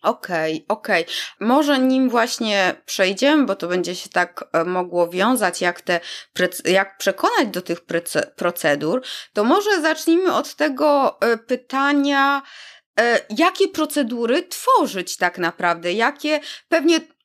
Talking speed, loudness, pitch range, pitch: 120 wpm, -20 LUFS, 180-295 Hz, 230 Hz